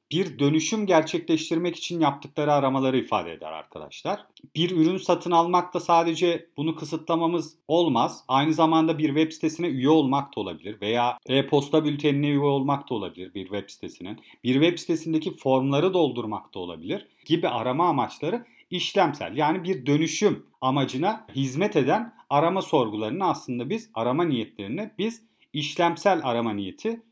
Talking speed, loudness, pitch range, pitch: 140 wpm, -25 LUFS, 135-170 Hz, 155 Hz